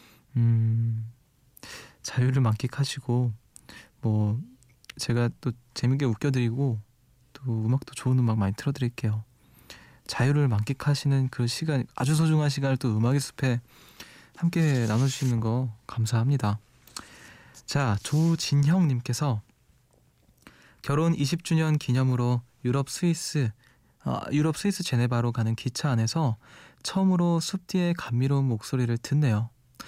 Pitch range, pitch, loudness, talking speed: 120-145 Hz, 130 Hz, -27 LUFS, 260 characters per minute